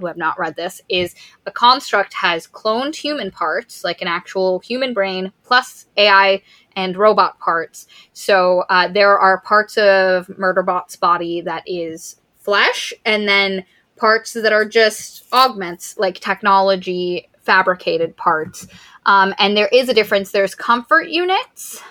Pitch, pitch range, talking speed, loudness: 195 Hz, 185-220 Hz, 145 wpm, -16 LUFS